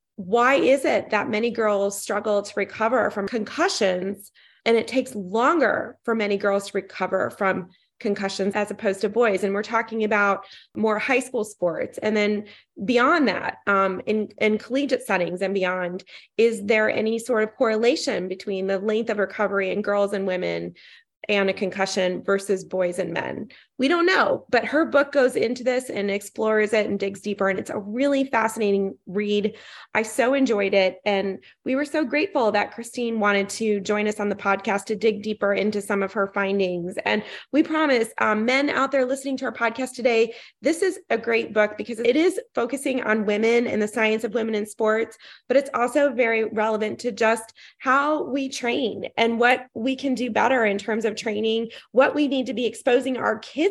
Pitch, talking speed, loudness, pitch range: 220 Hz, 190 wpm, -23 LUFS, 200-250 Hz